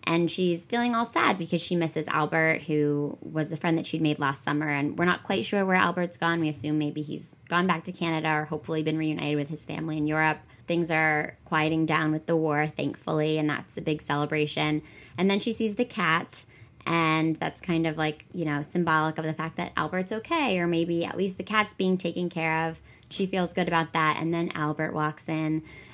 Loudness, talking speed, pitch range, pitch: -27 LUFS, 220 wpm, 155-175 Hz, 160 Hz